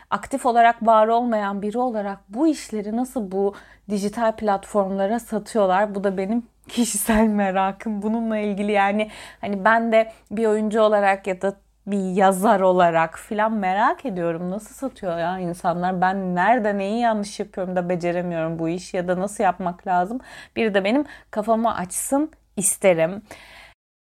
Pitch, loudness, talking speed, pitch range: 205 Hz, -22 LUFS, 145 wpm, 190-225 Hz